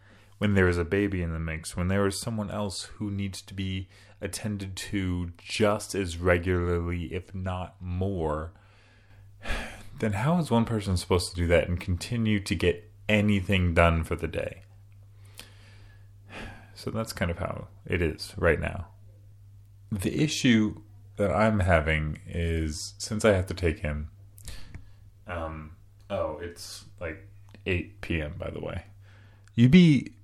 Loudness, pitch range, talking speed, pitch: -28 LUFS, 90-105 Hz, 150 wpm, 100 Hz